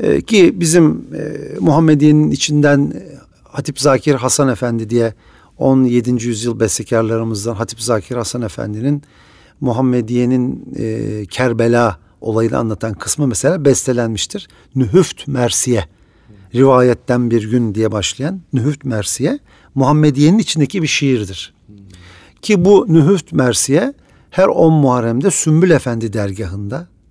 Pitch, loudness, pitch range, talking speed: 125 Hz, -14 LUFS, 110-145 Hz, 100 wpm